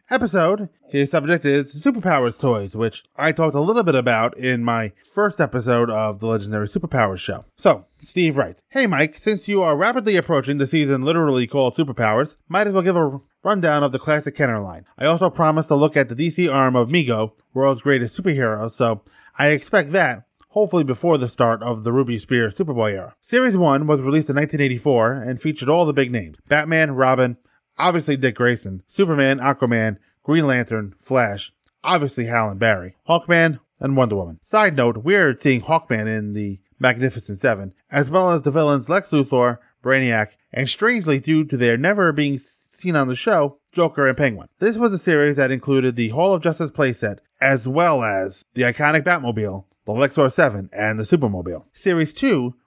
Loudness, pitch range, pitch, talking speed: -19 LUFS, 120-160 Hz, 135 Hz, 185 wpm